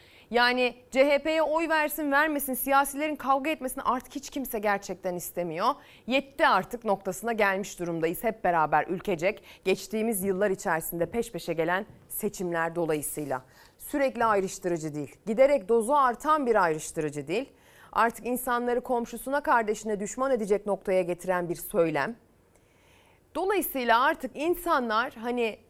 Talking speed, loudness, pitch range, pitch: 120 wpm, -27 LUFS, 185-265 Hz, 225 Hz